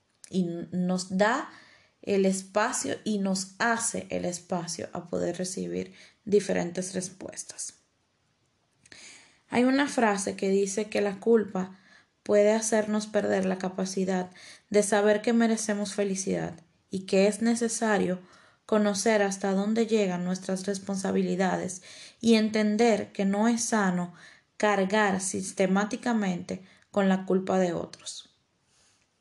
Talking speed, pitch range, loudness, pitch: 115 wpm, 185-215 Hz, -27 LUFS, 200 Hz